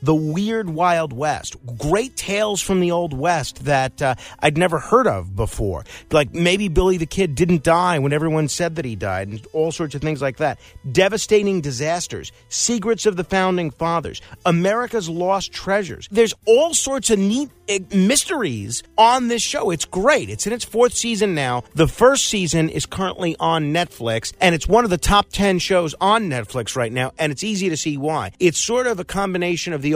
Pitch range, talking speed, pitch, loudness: 150-200 Hz, 190 wpm, 175 Hz, -19 LUFS